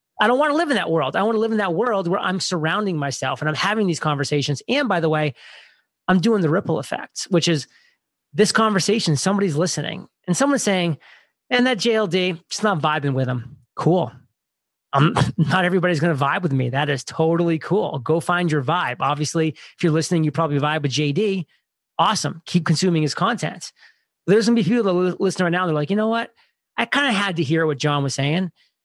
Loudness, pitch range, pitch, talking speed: -20 LUFS, 150-200 Hz, 170 Hz, 215 wpm